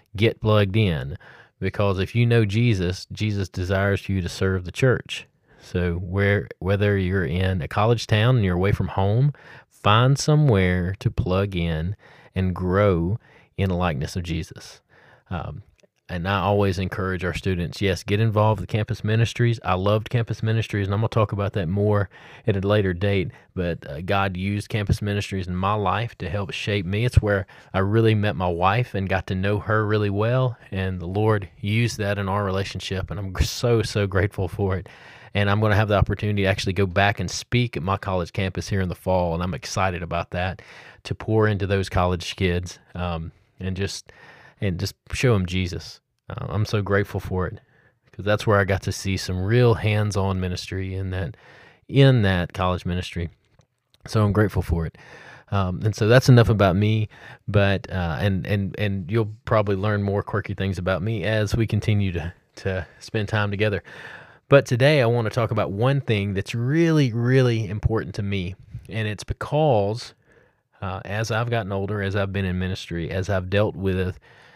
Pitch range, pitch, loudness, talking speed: 95-110 Hz, 100 Hz, -23 LUFS, 190 wpm